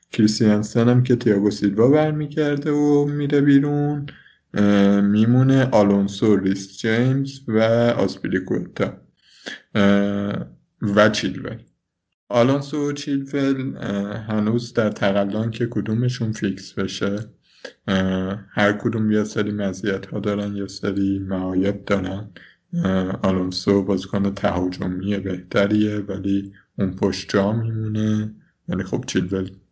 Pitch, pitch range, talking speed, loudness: 105 Hz, 100-120 Hz, 100 wpm, -21 LUFS